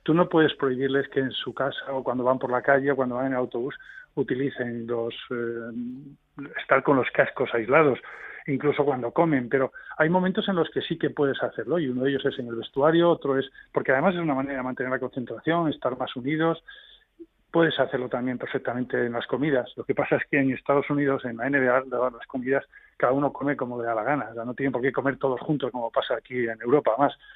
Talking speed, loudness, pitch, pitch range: 230 wpm, -25 LUFS, 135 Hz, 125-150 Hz